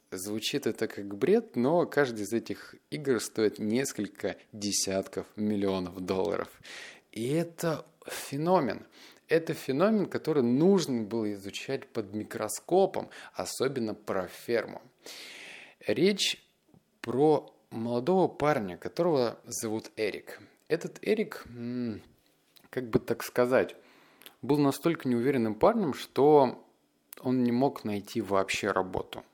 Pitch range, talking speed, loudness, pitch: 105-150 Hz, 105 wpm, -30 LUFS, 120 Hz